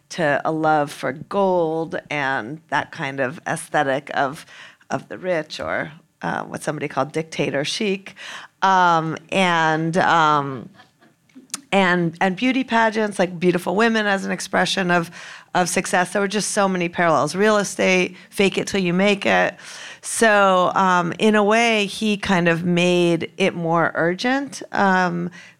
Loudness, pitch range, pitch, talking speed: -20 LUFS, 165-200 Hz, 180 Hz, 150 wpm